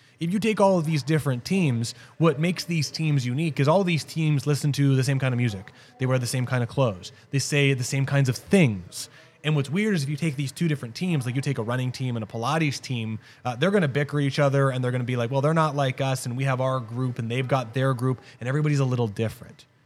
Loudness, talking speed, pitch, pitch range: -25 LUFS, 275 wpm, 135 Hz, 125-150 Hz